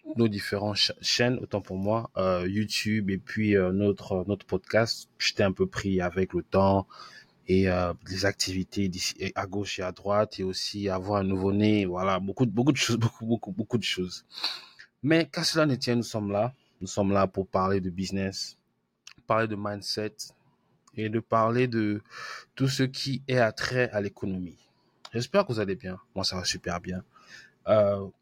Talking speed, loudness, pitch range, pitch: 190 wpm, -28 LUFS, 95-115 Hz, 100 Hz